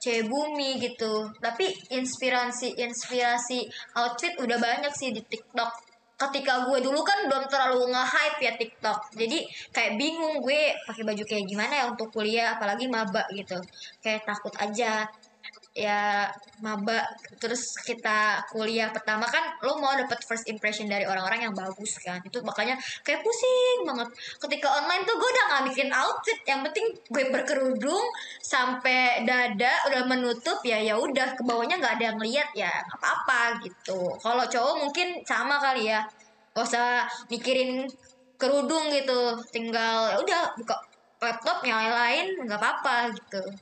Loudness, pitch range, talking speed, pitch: -27 LUFS, 220-275 Hz, 150 wpm, 240 Hz